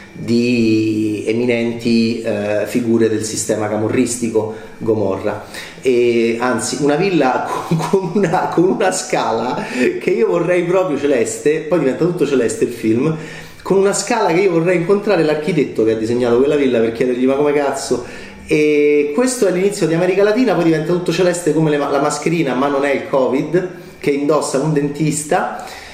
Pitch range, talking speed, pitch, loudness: 115-175 Hz, 165 wpm, 145 Hz, -16 LUFS